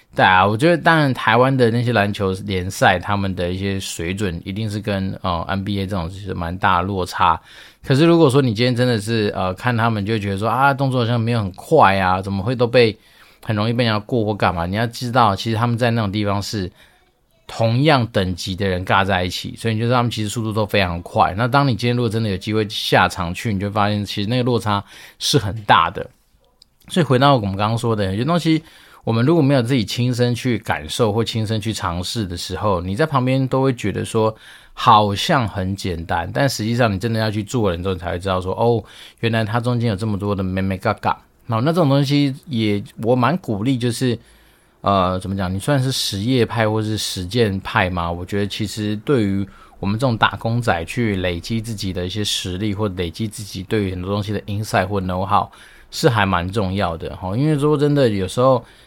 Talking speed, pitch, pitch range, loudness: 340 characters per minute, 110 Hz, 95-120 Hz, -19 LUFS